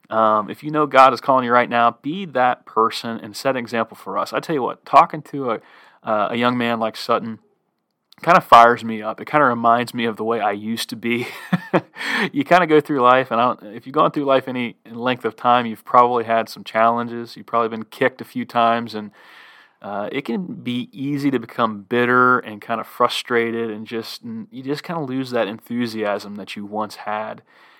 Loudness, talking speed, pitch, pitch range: -19 LUFS, 230 wpm, 120 Hz, 115-130 Hz